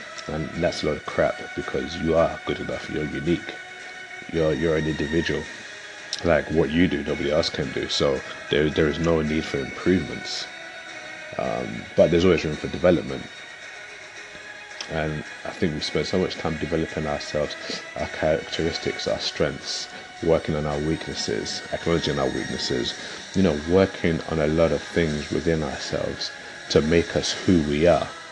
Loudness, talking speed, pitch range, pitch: -24 LUFS, 165 wpm, 75-85 Hz, 80 Hz